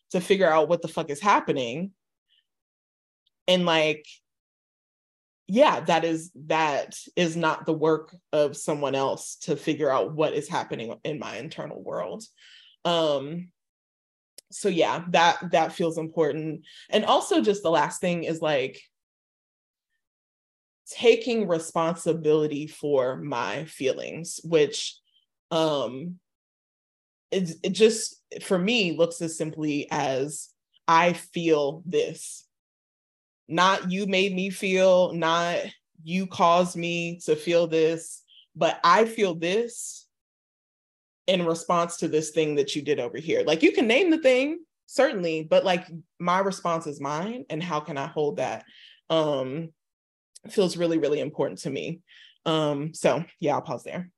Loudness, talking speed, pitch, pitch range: -25 LUFS, 135 wpm, 170 Hz, 155-185 Hz